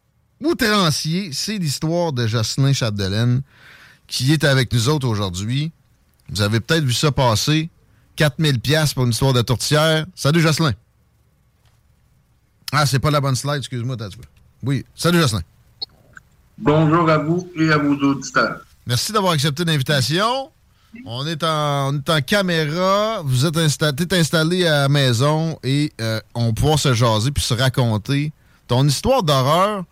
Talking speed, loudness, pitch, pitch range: 140 wpm, -18 LUFS, 145 Hz, 125-160 Hz